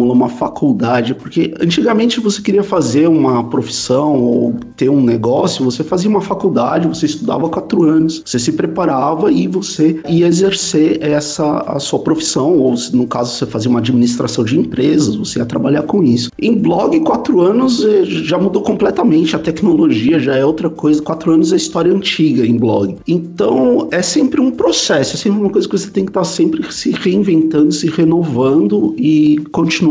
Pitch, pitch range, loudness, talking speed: 160 Hz, 135-190 Hz, -13 LUFS, 175 wpm